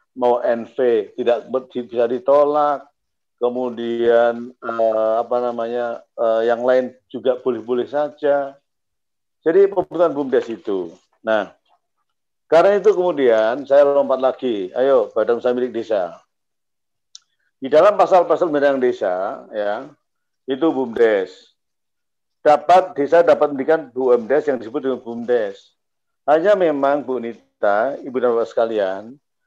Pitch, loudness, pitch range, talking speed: 130 Hz, -18 LUFS, 120-155 Hz, 110 wpm